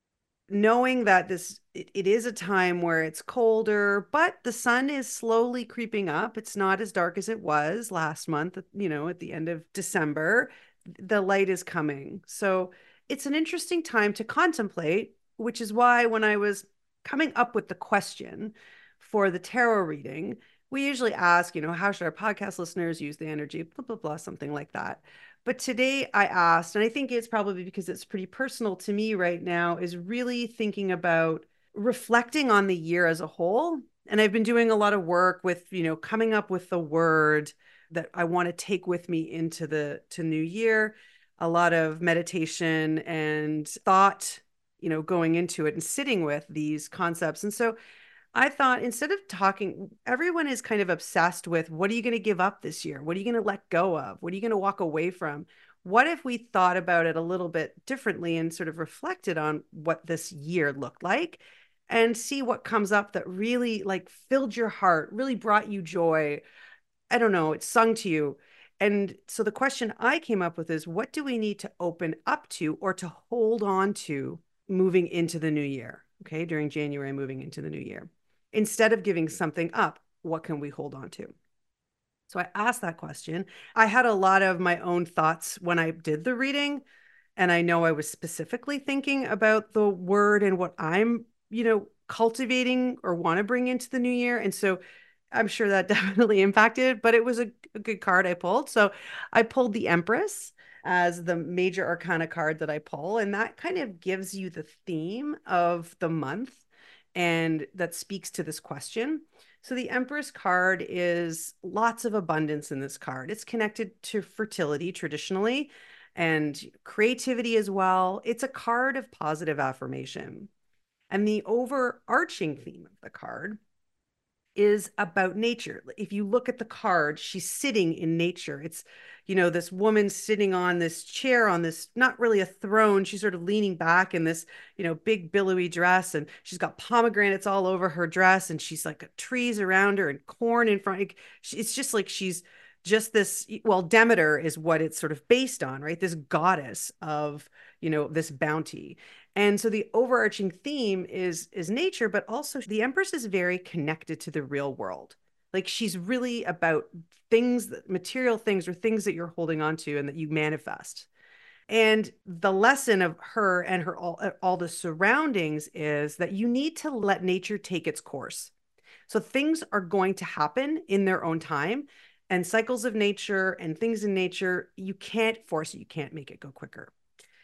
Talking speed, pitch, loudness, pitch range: 190 wpm, 195 Hz, -27 LUFS, 170-225 Hz